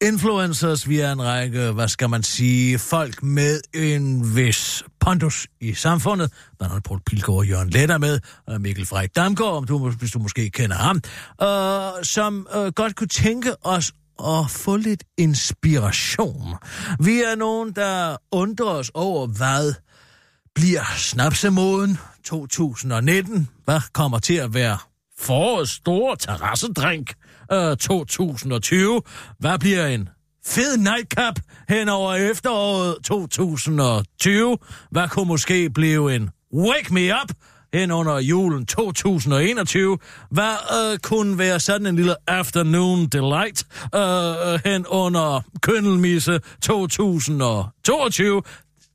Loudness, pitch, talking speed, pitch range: -20 LUFS, 165 Hz, 125 wpm, 125-190 Hz